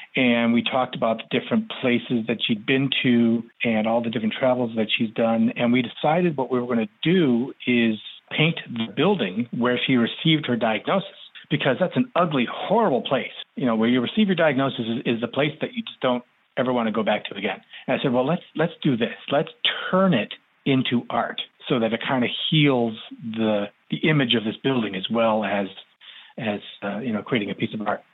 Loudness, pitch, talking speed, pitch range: -23 LUFS, 125 Hz, 220 wpm, 115-145 Hz